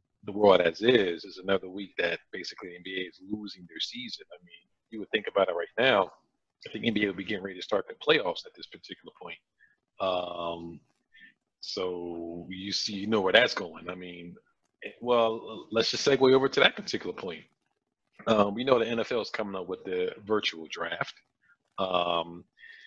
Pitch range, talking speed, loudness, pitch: 90-120 Hz, 190 wpm, -28 LUFS, 100 Hz